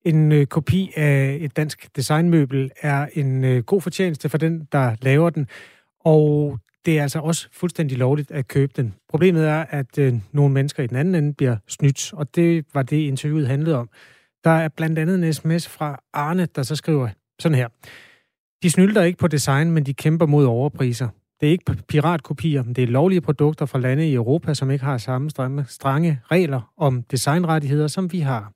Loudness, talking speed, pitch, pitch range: -20 LUFS, 190 wpm, 150 Hz, 135-160 Hz